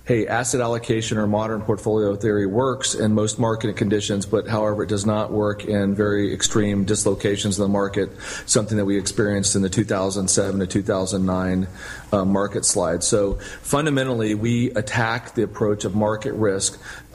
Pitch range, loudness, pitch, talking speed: 100-110 Hz, -21 LUFS, 105 Hz, 160 wpm